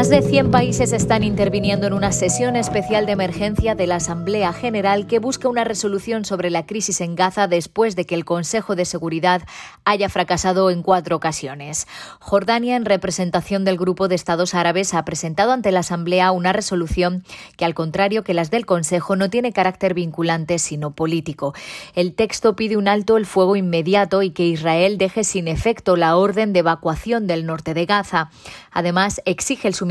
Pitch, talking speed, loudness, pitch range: 185 Hz, 185 wpm, -19 LUFS, 170-205 Hz